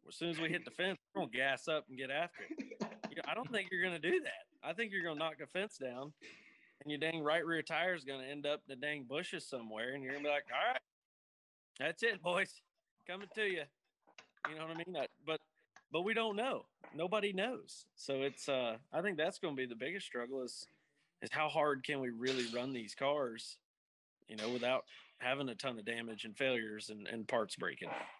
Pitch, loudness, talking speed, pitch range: 145 Hz, -40 LUFS, 230 wpm, 130-180 Hz